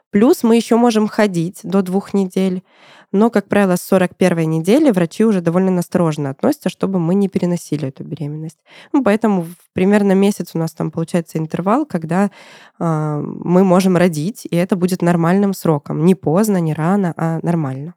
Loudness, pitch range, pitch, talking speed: -16 LUFS, 165-200 Hz, 185 Hz, 165 wpm